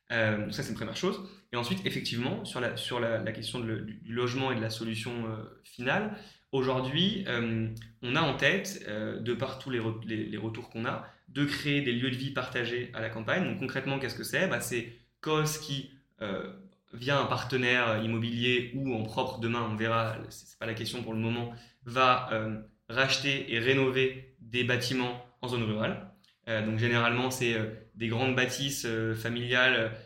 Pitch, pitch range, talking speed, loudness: 120 Hz, 115-130 Hz, 195 wpm, -31 LUFS